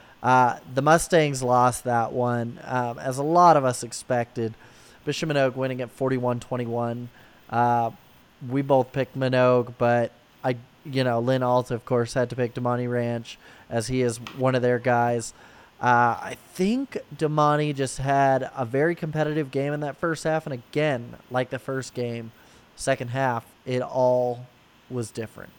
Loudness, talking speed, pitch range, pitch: -24 LUFS, 165 wpm, 120-135 Hz, 125 Hz